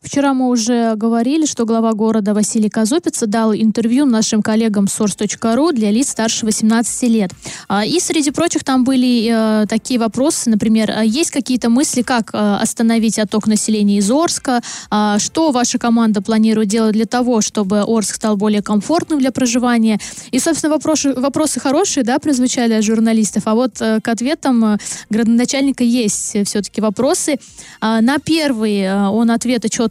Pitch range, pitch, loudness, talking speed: 220-260 Hz, 230 Hz, -15 LUFS, 145 wpm